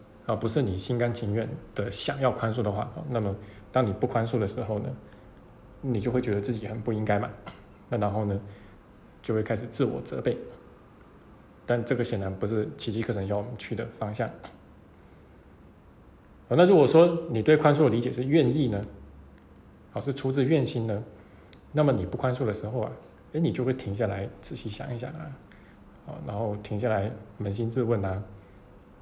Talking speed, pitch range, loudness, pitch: 265 characters per minute, 100-125 Hz, -28 LUFS, 110 Hz